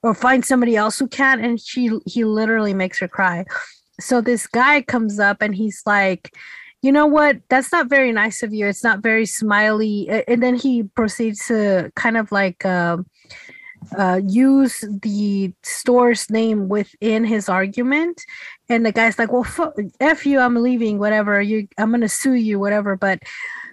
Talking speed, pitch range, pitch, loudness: 175 wpm, 205-250 Hz, 225 Hz, -18 LUFS